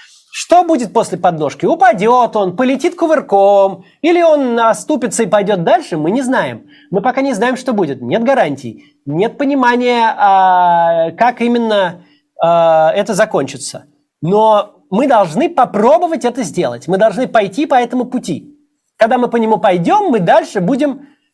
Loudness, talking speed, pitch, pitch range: -13 LUFS, 145 wpm, 230 Hz, 190-280 Hz